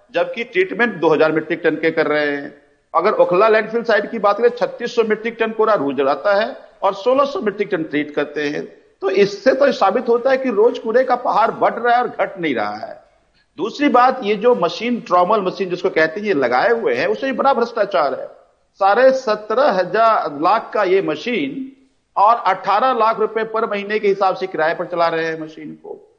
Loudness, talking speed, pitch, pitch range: -17 LUFS, 215 wpm, 215 Hz, 175-245 Hz